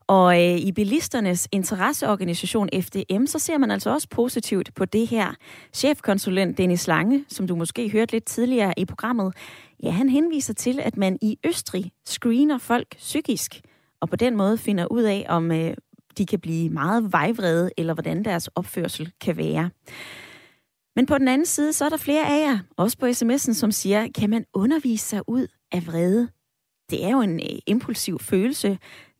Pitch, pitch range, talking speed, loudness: 210 Hz, 180-245 Hz, 180 wpm, -23 LUFS